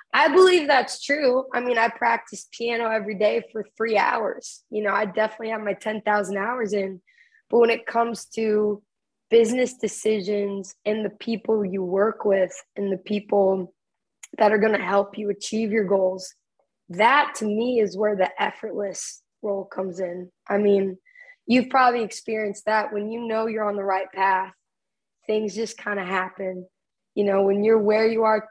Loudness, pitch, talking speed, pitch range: -23 LUFS, 215 Hz, 175 wpm, 195-225 Hz